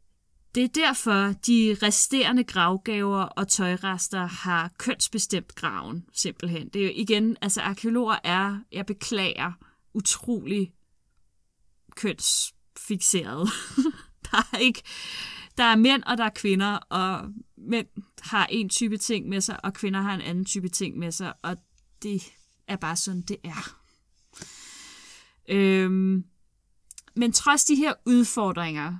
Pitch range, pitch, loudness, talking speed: 185-230 Hz, 200 Hz, -25 LUFS, 130 wpm